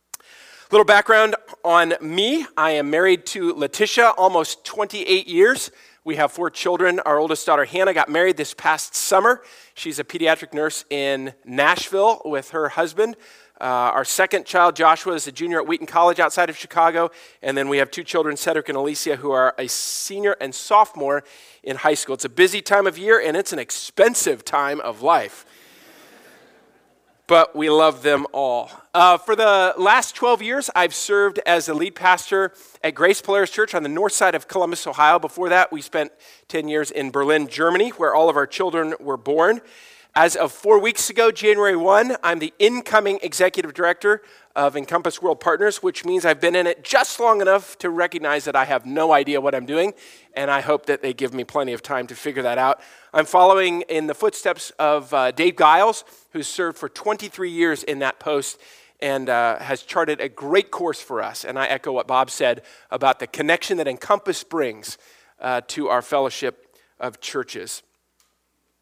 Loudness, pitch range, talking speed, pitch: -19 LUFS, 150-195 Hz, 190 wpm, 170 Hz